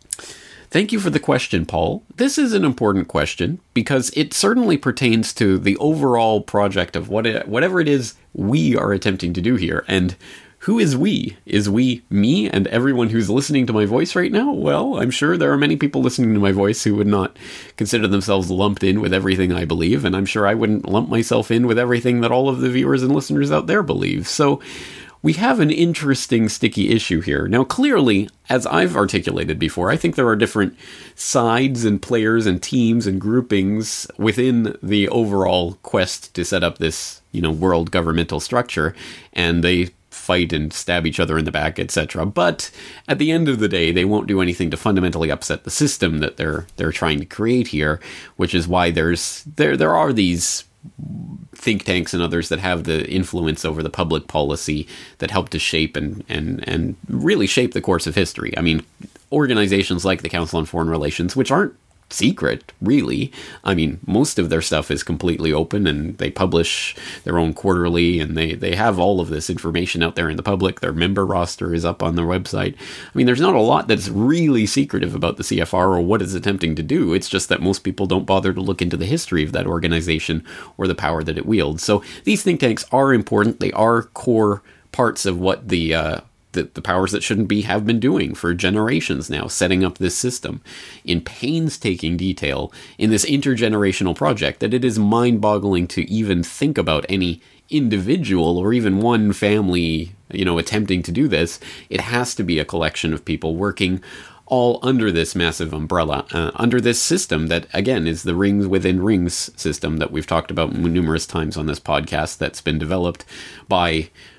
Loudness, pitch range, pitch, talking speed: -19 LUFS, 85-115 Hz, 95 Hz, 200 wpm